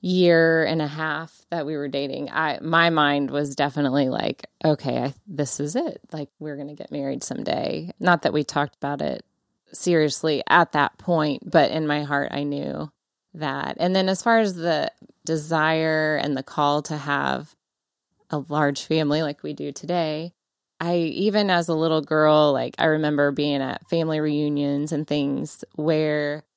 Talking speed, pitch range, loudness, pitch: 175 wpm, 145-165 Hz, -23 LUFS, 155 Hz